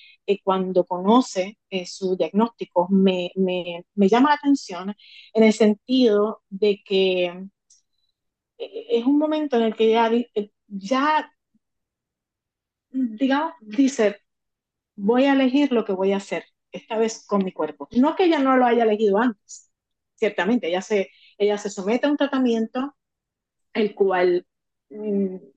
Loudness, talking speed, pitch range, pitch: -22 LUFS, 140 wpm, 190-250 Hz, 215 Hz